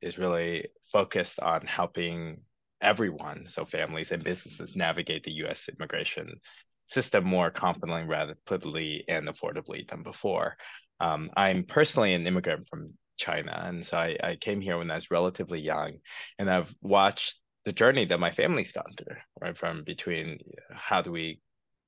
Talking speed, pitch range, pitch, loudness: 155 wpm, 85-90 Hz, 85 Hz, -29 LUFS